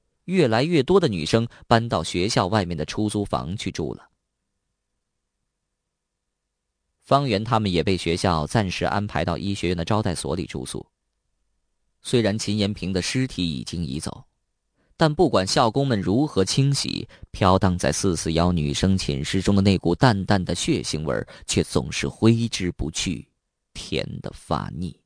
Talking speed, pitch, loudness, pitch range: 230 characters per minute, 95 Hz, -23 LUFS, 85-110 Hz